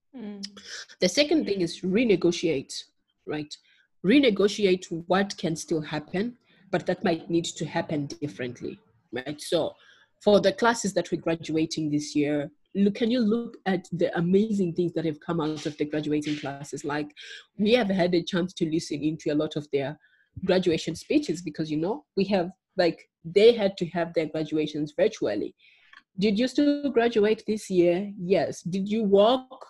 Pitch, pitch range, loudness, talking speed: 175 Hz, 160-205 Hz, -26 LUFS, 165 wpm